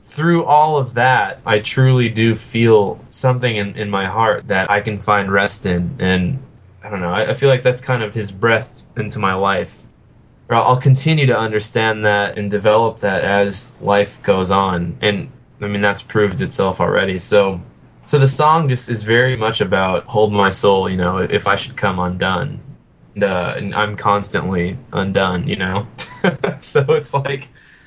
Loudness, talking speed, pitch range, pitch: -16 LUFS, 185 wpm, 100-125 Hz, 105 Hz